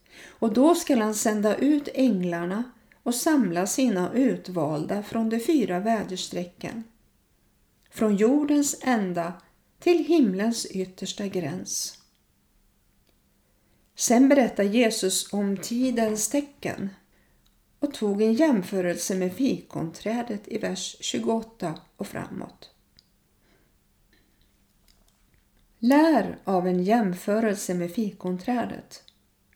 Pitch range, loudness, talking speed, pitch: 185-245 Hz, -25 LUFS, 90 wpm, 220 Hz